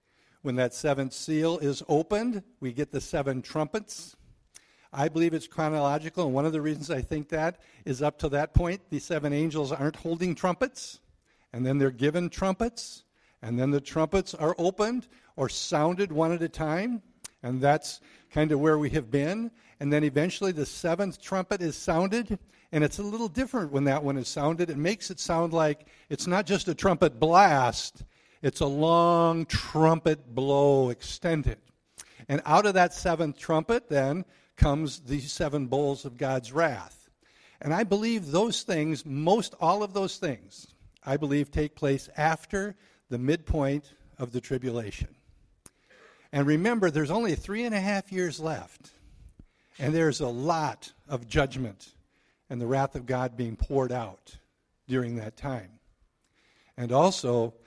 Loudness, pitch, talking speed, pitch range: -28 LUFS, 155 Hz, 165 wpm, 135-175 Hz